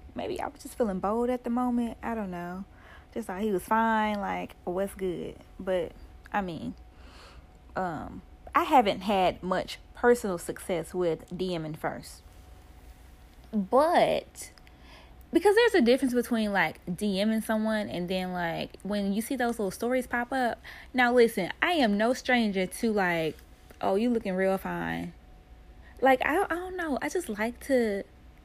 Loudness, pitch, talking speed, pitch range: -28 LUFS, 210 Hz, 160 wpm, 175-245 Hz